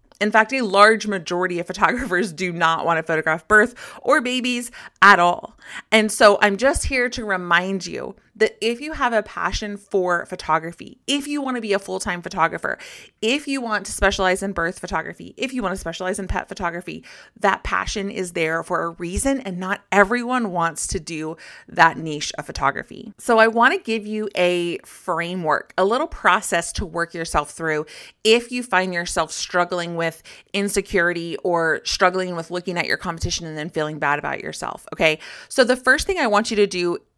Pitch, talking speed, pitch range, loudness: 190 Hz, 190 wpm, 170-220 Hz, -20 LUFS